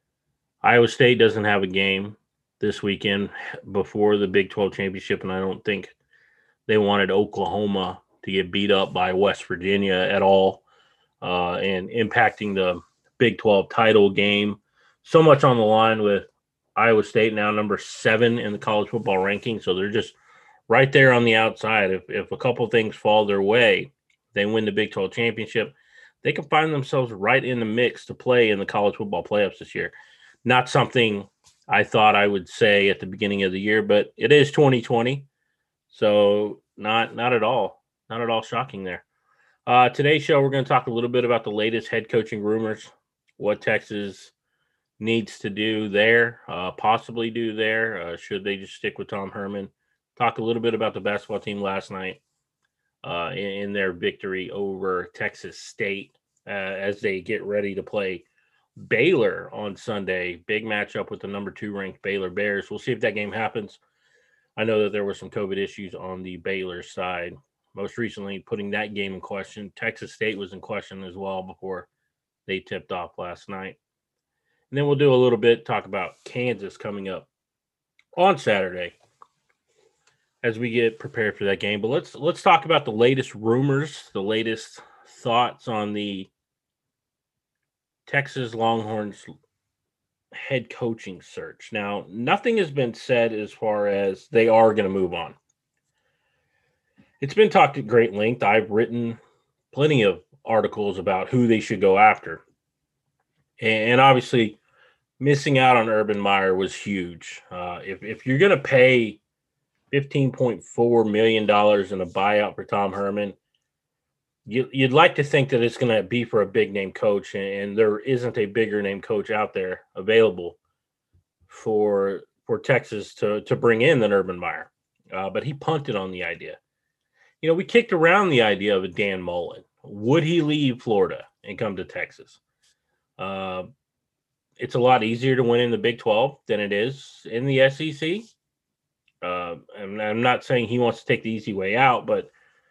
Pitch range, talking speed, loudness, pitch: 100-120 Hz, 175 wpm, -22 LUFS, 105 Hz